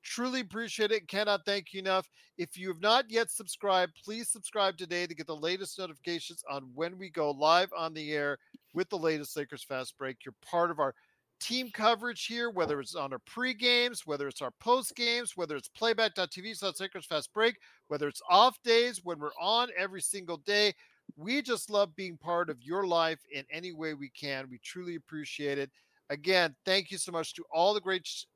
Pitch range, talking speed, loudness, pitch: 160-220 Hz, 200 wpm, -32 LUFS, 185 Hz